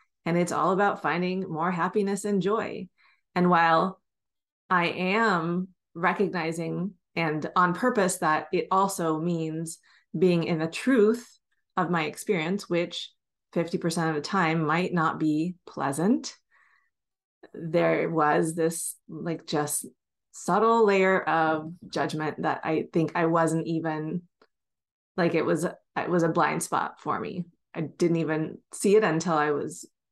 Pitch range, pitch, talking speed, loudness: 160-190 Hz, 170 Hz, 140 wpm, -26 LUFS